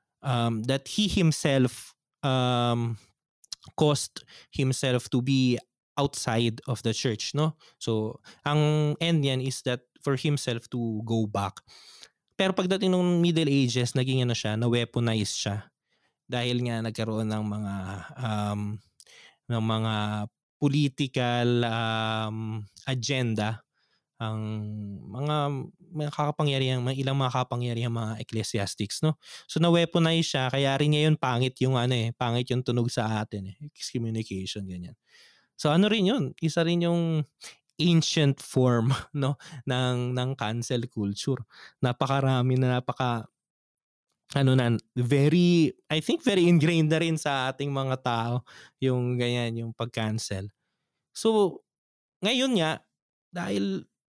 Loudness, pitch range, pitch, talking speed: -27 LUFS, 115-150 Hz, 125 Hz, 125 wpm